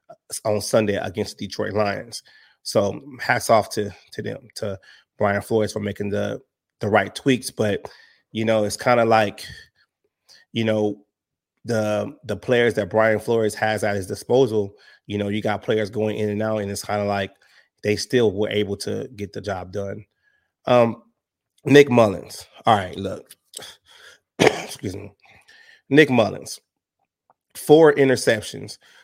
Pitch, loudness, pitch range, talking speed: 105 Hz, -21 LUFS, 105-115 Hz, 155 wpm